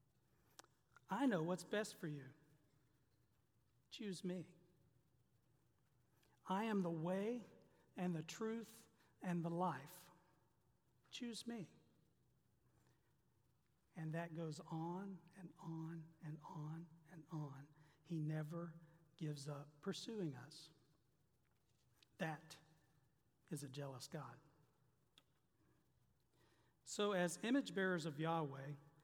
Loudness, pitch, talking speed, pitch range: -47 LUFS, 160 Hz, 95 wpm, 140-180 Hz